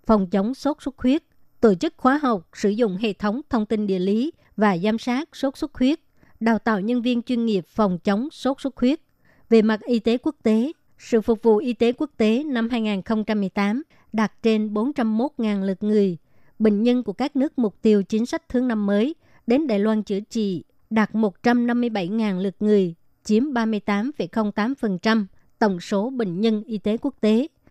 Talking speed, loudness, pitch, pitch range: 185 wpm, -22 LUFS, 225 Hz, 210-245 Hz